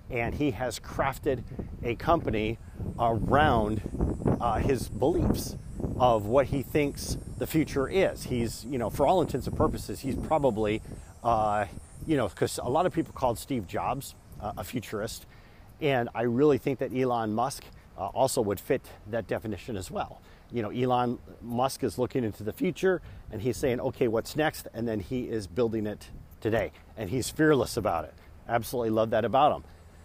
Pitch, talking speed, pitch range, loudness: 115 Hz, 175 wpm, 105-130 Hz, -29 LUFS